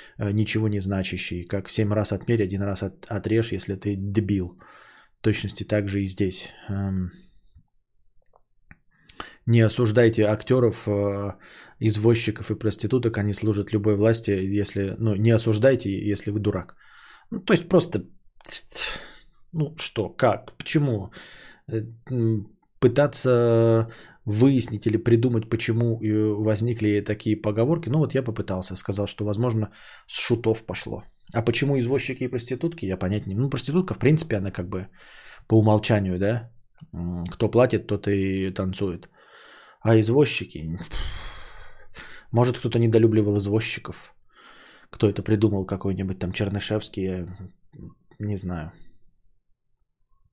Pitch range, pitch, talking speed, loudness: 100-115 Hz, 110 Hz, 120 wpm, -24 LUFS